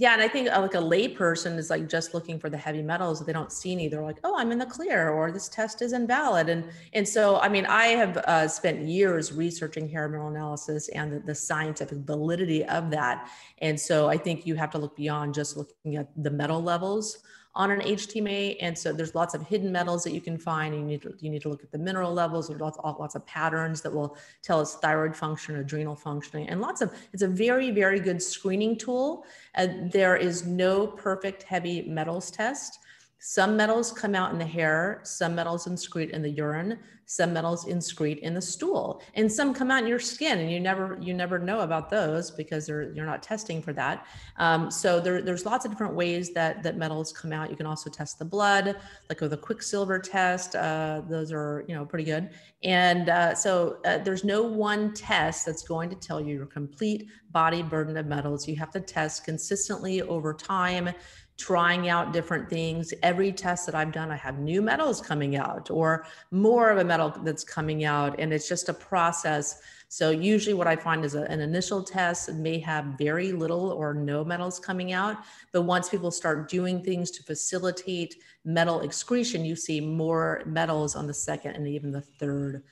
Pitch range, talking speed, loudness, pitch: 155-190 Hz, 215 wpm, -28 LUFS, 170 Hz